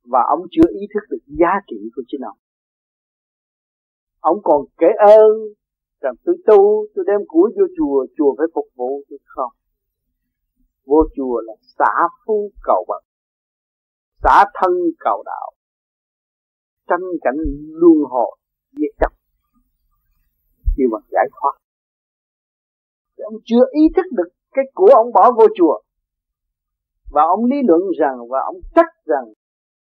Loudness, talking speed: -16 LUFS, 140 wpm